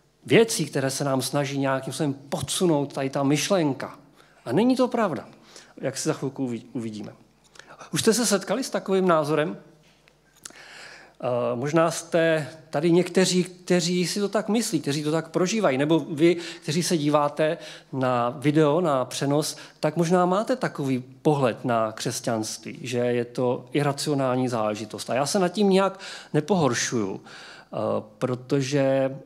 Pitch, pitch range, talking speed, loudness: 150 Hz, 135-175 Hz, 140 wpm, -24 LUFS